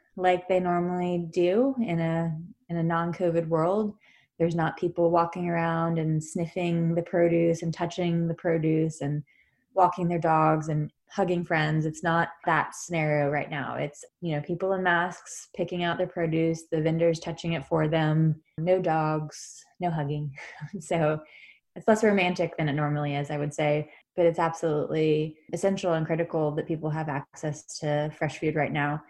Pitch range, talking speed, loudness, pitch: 155-175 Hz, 170 wpm, -27 LUFS, 165 Hz